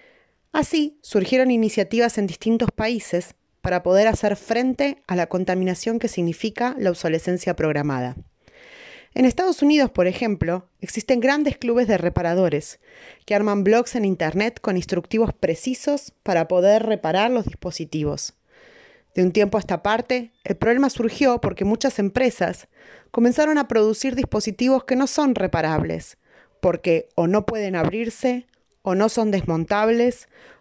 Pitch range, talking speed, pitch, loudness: 180-255 Hz, 135 wpm, 220 Hz, -21 LUFS